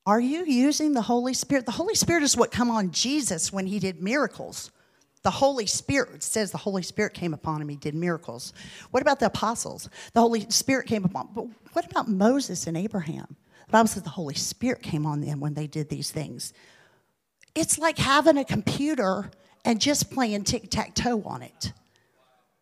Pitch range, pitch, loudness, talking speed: 175-255 Hz, 215 Hz, -25 LUFS, 190 wpm